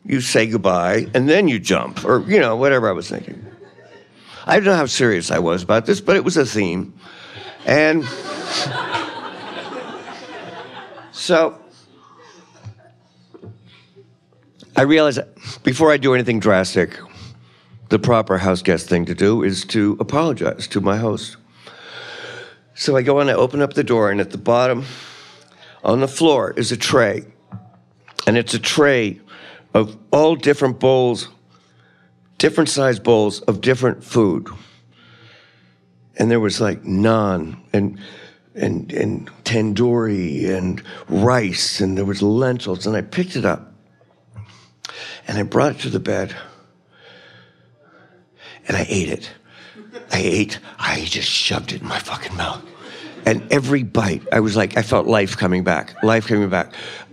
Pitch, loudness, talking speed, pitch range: 110 Hz, -18 LUFS, 145 wpm, 90-125 Hz